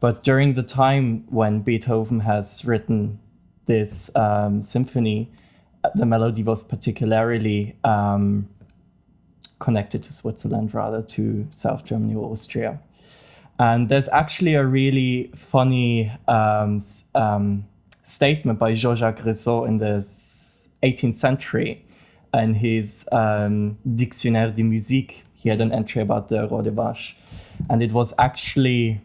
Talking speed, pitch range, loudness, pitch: 120 wpm, 105-125 Hz, -22 LUFS, 115 Hz